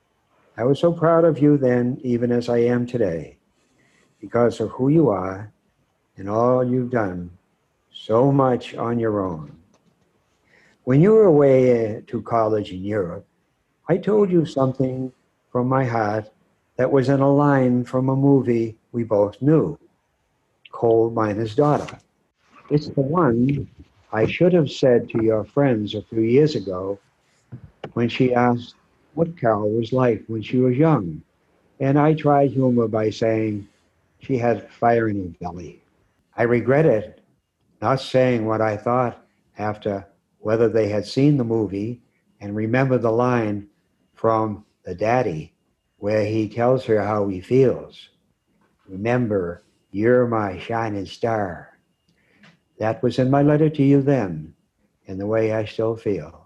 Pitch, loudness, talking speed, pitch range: 120 Hz, -20 LUFS, 150 wpm, 110-135 Hz